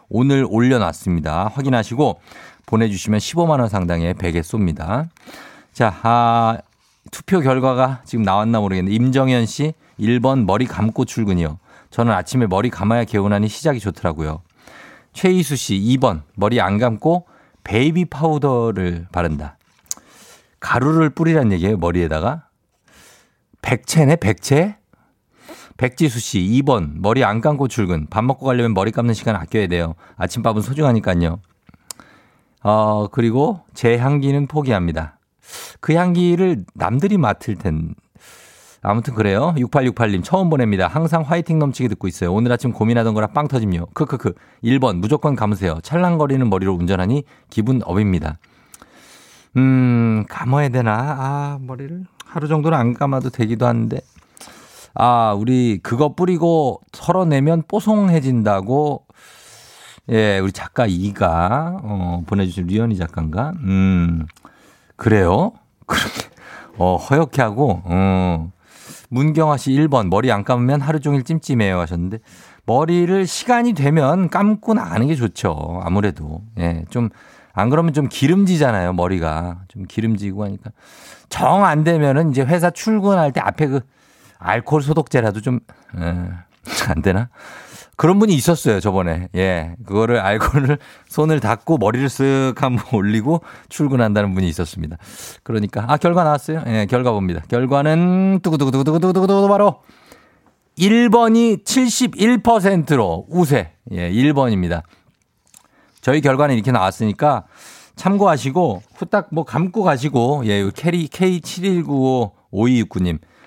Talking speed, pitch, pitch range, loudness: 285 characters per minute, 120 Hz, 100-150 Hz, -18 LUFS